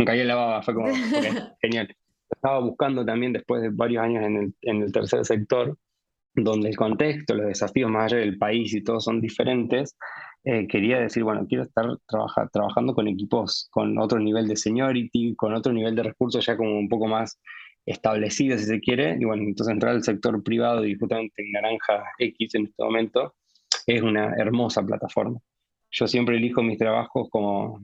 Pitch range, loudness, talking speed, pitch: 110-120 Hz, -24 LUFS, 190 wpm, 115 Hz